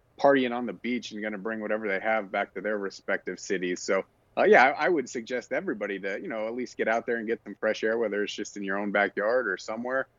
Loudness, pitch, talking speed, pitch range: -28 LUFS, 110 Hz, 270 wpm, 100-115 Hz